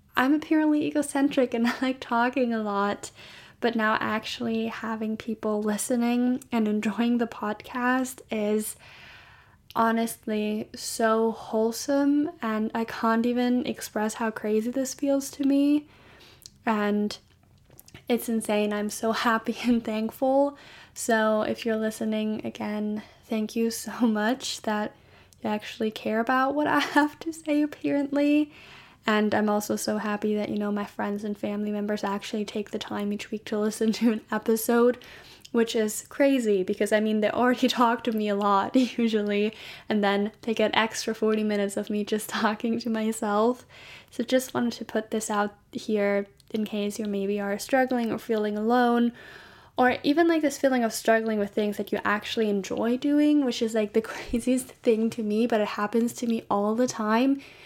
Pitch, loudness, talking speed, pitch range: 225 Hz, -26 LUFS, 165 wpm, 215-245 Hz